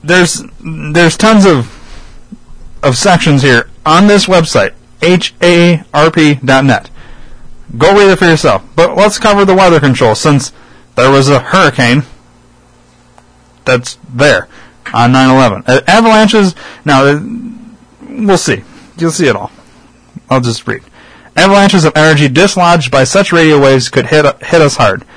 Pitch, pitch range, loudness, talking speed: 160 Hz, 135-190 Hz, -8 LUFS, 135 wpm